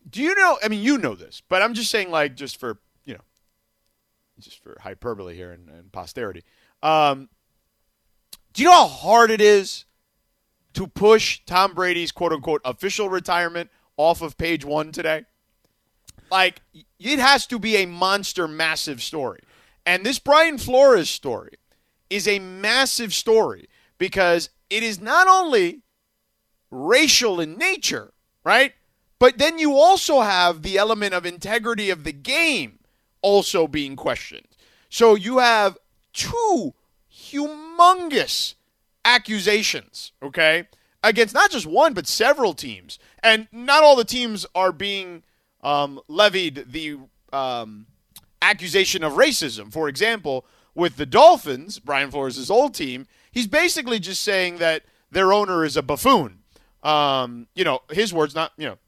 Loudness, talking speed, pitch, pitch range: -19 LUFS, 145 wpm, 190 Hz, 155-235 Hz